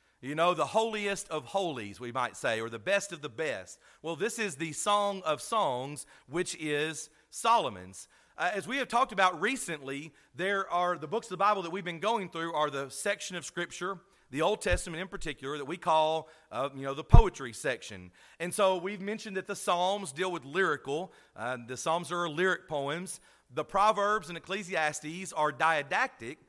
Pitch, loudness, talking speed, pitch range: 175 Hz, -31 LUFS, 195 wpm, 150-195 Hz